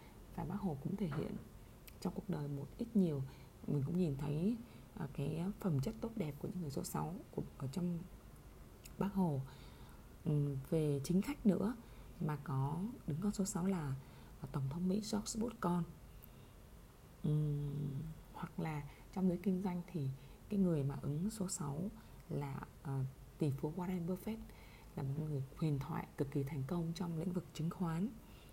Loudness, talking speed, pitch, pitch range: -41 LUFS, 165 wpm, 160 Hz, 140-185 Hz